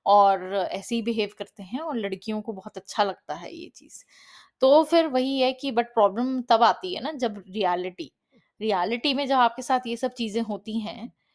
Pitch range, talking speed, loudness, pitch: 205-255 Hz, 200 wpm, -25 LUFS, 230 Hz